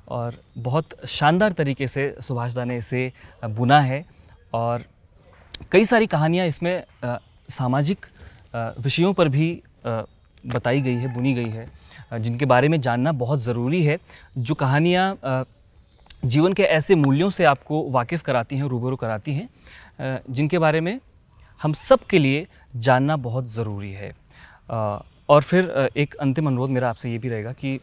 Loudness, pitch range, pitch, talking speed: -22 LUFS, 120-155 Hz, 135 Hz, 145 wpm